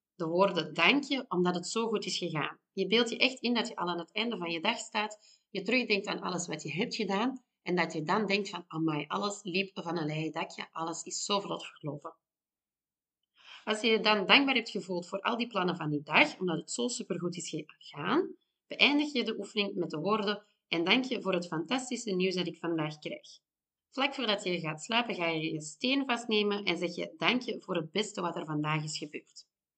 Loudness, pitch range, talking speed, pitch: -31 LUFS, 170-225 Hz, 230 wpm, 195 Hz